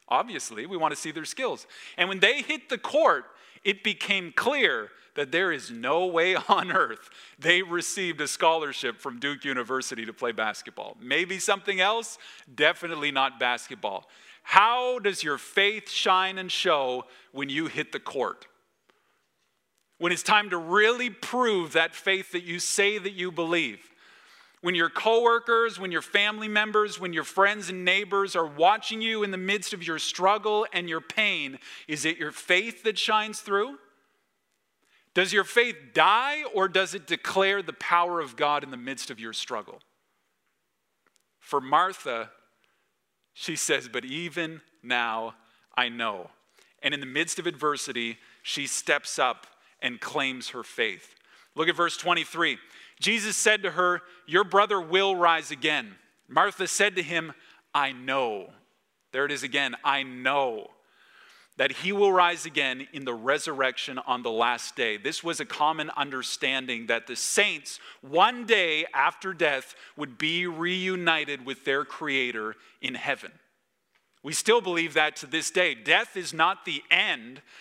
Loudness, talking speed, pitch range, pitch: -26 LUFS, 160 wpm, 150-200 Hz, 175 Hz